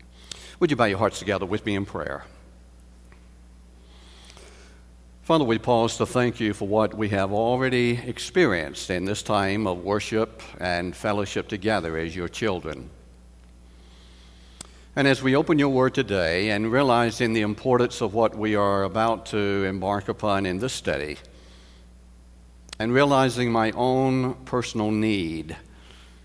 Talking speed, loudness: 140 wpm, -24 LUFS